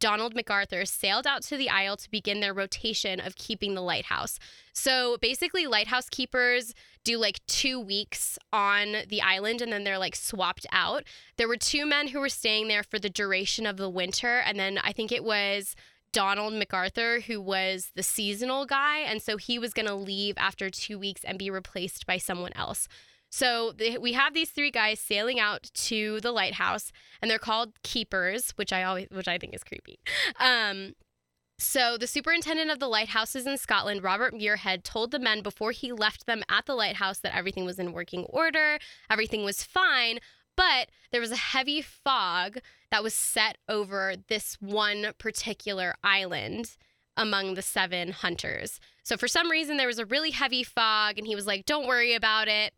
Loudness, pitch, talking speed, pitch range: -27 LUFS, 215 Hz, 185 wpm, 195-245 Hz